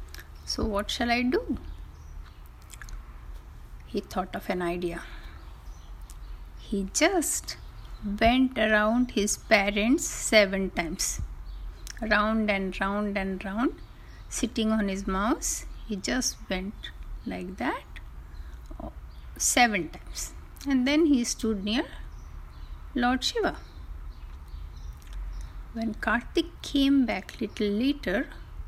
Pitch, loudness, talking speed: 195 Hz, -27 LUFS, 100 wpm